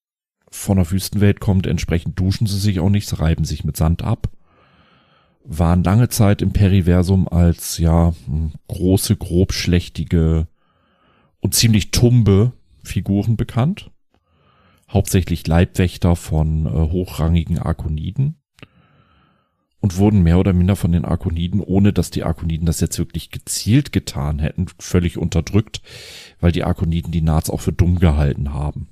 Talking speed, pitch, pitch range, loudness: 135 wpm, 90 Hz, 85-100 Hz, -18 LUFS